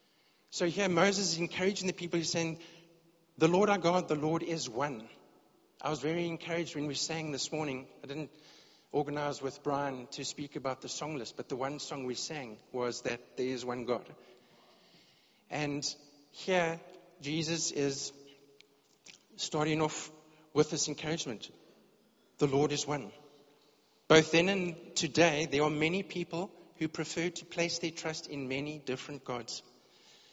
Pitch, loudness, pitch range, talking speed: 155 Hz, -33 LUFS, 140-170 Hz, 160 wpm